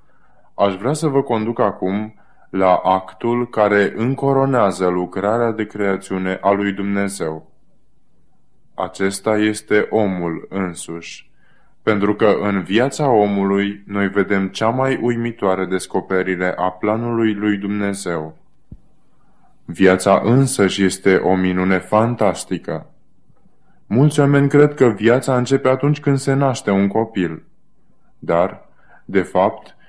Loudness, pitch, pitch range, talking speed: -18 LUFS, 100 Hz, 95-120 Hz, 110 wpm